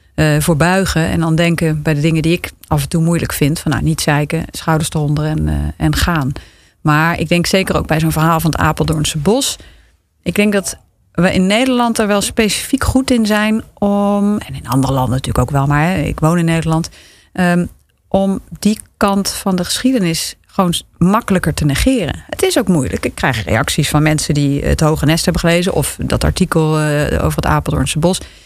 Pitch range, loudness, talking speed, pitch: 155-195 Hz, -15 LUFS, 205 wpm, 165 Hz